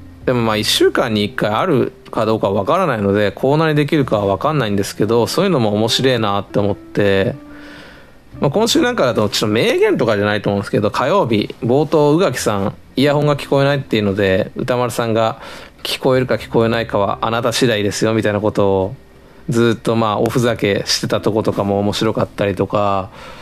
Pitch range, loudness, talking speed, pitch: 100-130 Hz, -16 LUFS, 425 characters per minute, 110 Hz